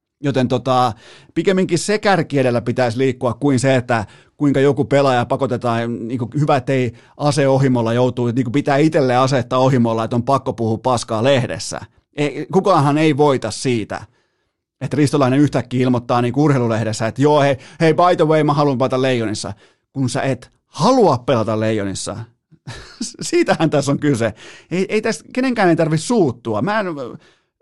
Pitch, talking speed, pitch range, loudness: 130 Hz, 160 wpm, 120-150 Hz, -17 LUFS